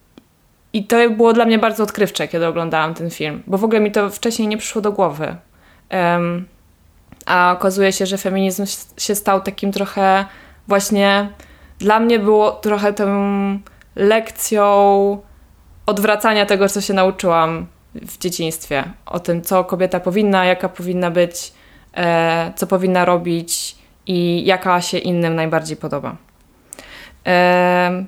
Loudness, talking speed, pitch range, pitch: -17 LUFS, 135 wpm, 170-205 Hz, 190 Hz